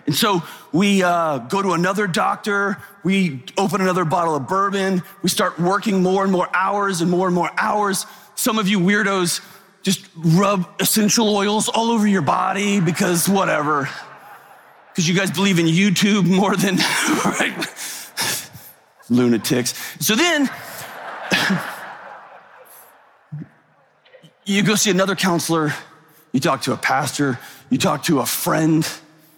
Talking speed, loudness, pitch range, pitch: 135 wpm, -19 LUFS, 170-200 Hz, 190 Hz